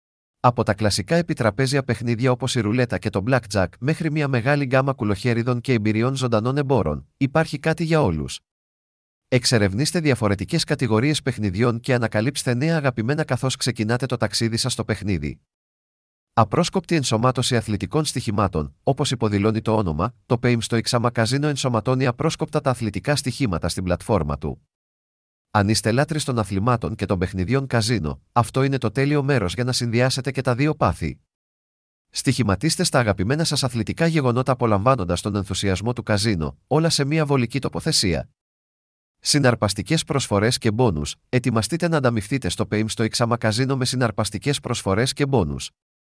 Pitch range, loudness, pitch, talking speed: 105-135 Hz, -21 LUFS, 120 Hz, 145 wpm